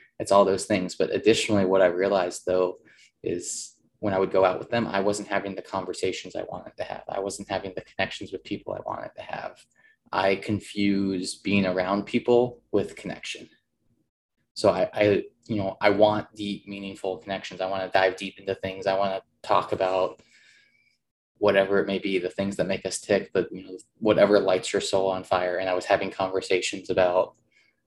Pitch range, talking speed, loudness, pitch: 95-100 Hz, 200 wpm, -26 LUFS, 95 Hz